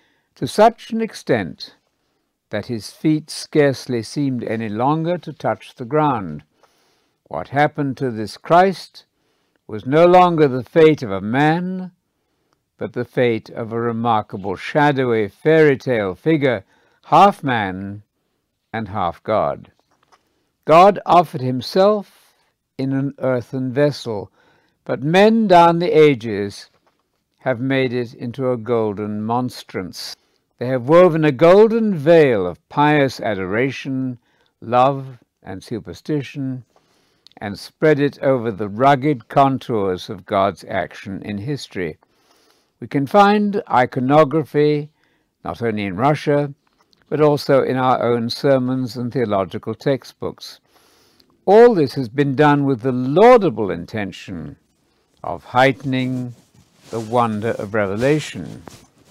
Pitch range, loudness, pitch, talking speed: 120-150 Hz, -17 LUFS, 135 Hz, 120 wpm